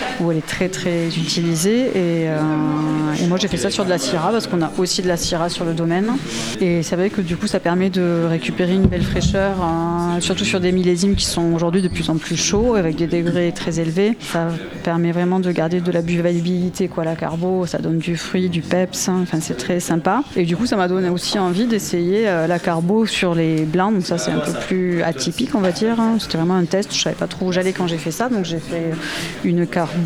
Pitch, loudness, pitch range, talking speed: 175 Hz, -19 LUFS, 170-190 Hz, 250 wpm